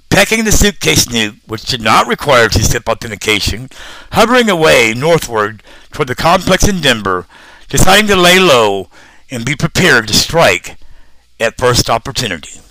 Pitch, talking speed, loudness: 120 Hz, 140 wpm, -10 LUFS